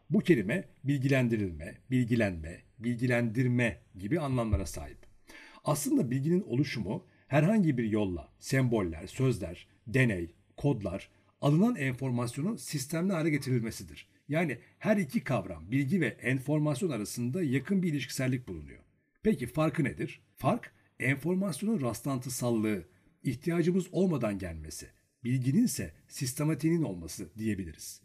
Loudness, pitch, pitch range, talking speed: -31 LUFS, 125 Hz, 100-155 Hz, 105 wpm